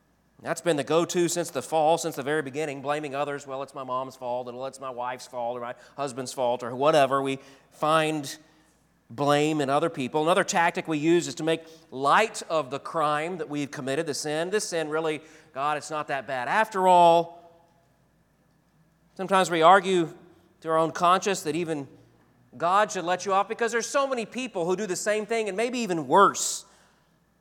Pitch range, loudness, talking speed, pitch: 140-180 Hz, -25 LUFS, 195 wpm, 160 Hz